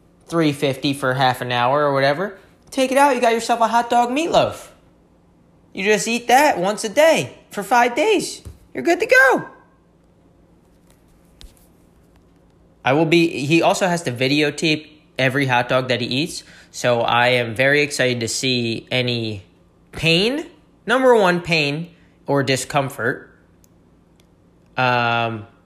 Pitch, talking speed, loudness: 150 Hz, 140 wpm, -18 LUFS